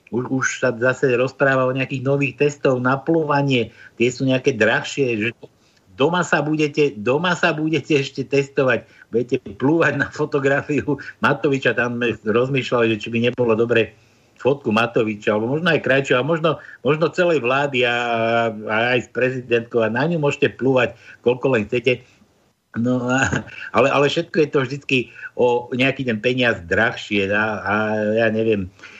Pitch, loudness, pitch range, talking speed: 130 Hz, -19 LUFS, 115-145 Hz, 155 wpm